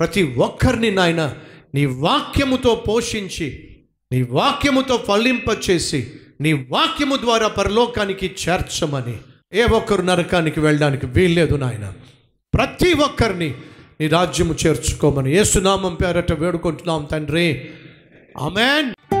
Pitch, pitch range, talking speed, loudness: 175 Hz, 155-215 Hz, 95 wpm, -18 LUFS